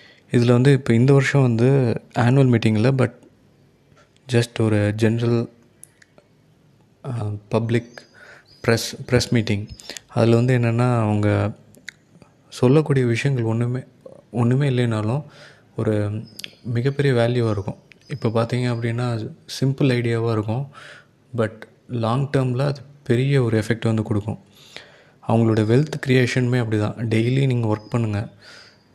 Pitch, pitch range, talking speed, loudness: 120 Hz, 115-135 Hz, 110 wpm, -20 LUFS